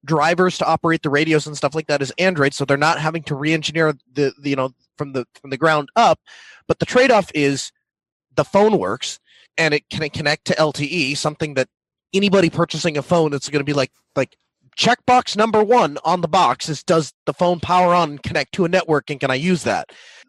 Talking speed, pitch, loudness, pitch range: 225 wpm, 155 Hz, -19 LUFS, 145-175 Hz